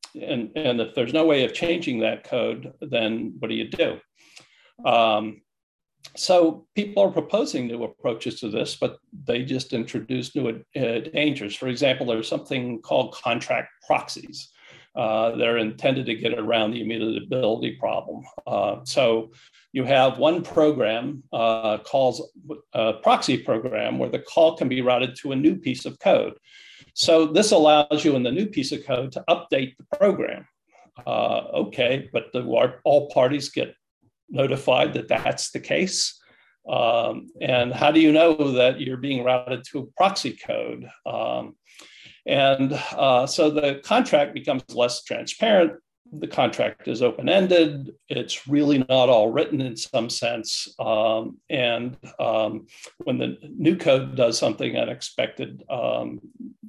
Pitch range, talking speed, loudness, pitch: 120-155 Hz, 150 wpm, -23 LUFS, 135 Hz